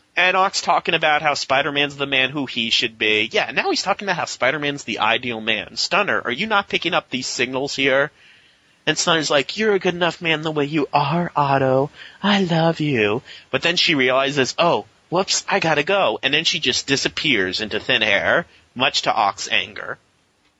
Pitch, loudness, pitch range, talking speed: 145 Hz, -19 LUFS, 130-175 Hz, 205 wpm